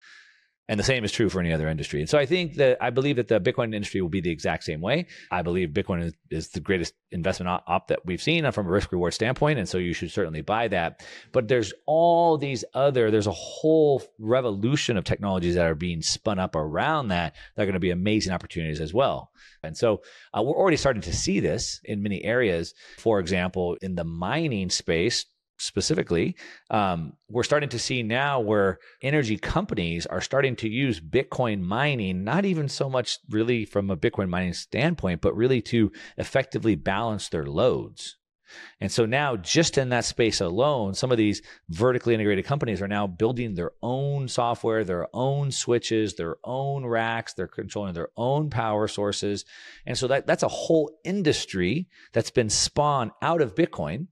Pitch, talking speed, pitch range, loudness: 110 Hz, 195 wpm, 95-135 Hz, -25 LUFS